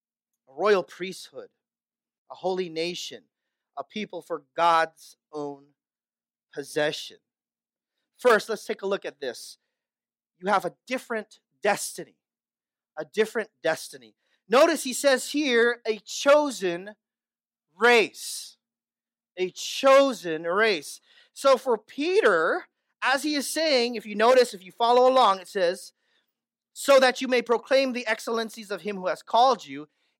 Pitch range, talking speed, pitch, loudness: 185-260 Hz, 130 wpm, 230 Hz, -24 LUFS